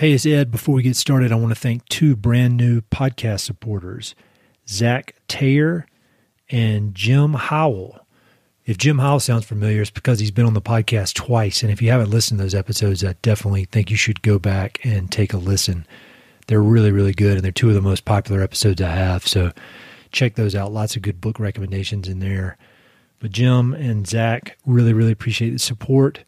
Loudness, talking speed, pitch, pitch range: -19 LUFS, 200 wpm, 110 Hz, 100-125 Hz